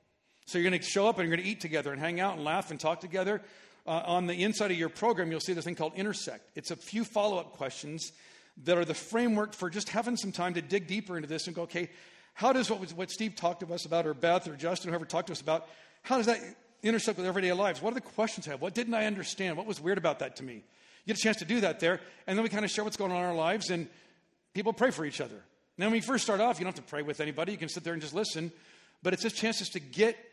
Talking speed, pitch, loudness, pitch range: 300 wpm, 185 Hz, -32 LUFS, 170-210 Hz